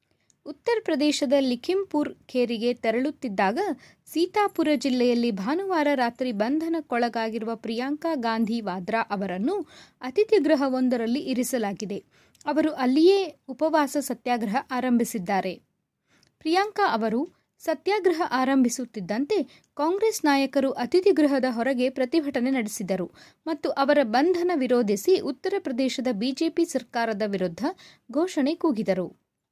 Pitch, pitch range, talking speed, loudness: 265 Hz, 235-315 Hz, 85 wpm, -25 LUFS